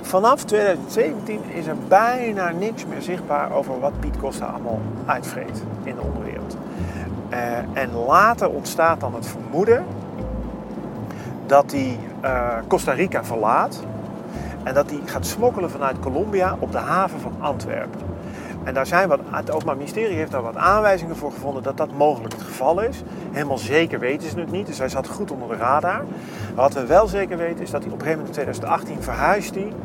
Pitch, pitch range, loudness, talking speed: 145 Hz, 120-190 Hz, -22 LUFS, 180 wpm